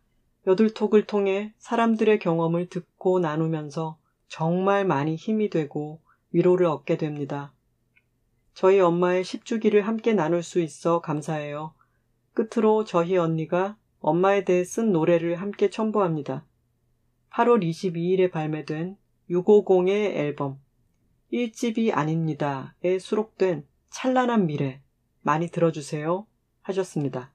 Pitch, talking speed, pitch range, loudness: 175 Hz, 250 characters per minute, 150-200 Hz, -24 LUFS